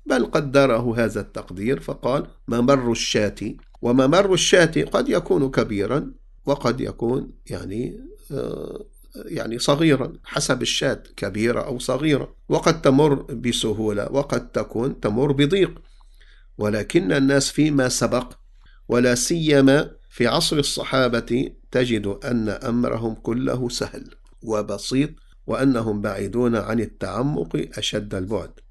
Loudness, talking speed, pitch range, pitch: -21 LUFS, 105 wpm, 115-140 Hz, 125 Hz